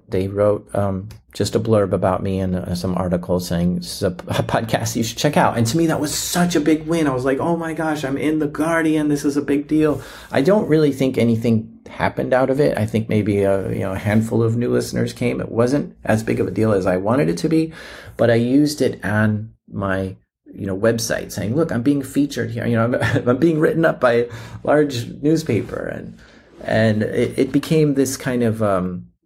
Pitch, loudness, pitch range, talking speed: 115 Hz, -19 LUFS, 105-145 Hz, 240 wpm